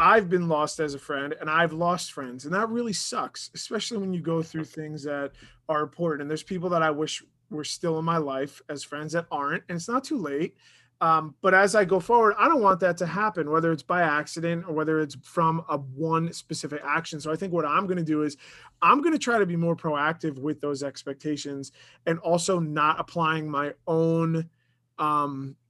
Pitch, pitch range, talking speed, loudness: 160 Hz, 150-175 Hz, 220 wpm, -26 LUFS